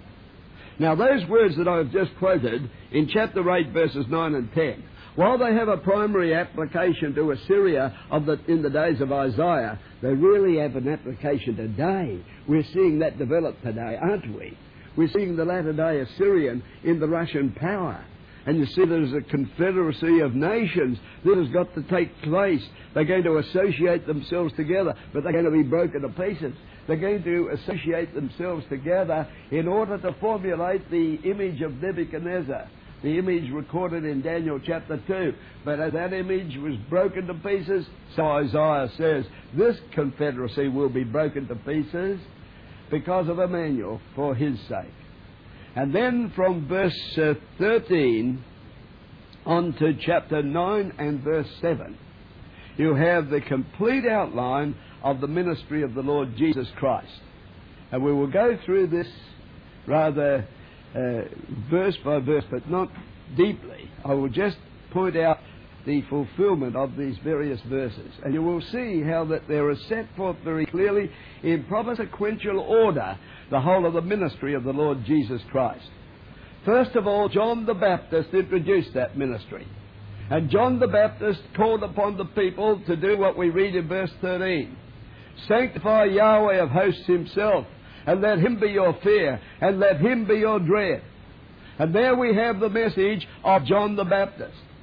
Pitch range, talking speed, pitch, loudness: 140-190 Hz, 160 wpm, 165 Hz, -24 LUFS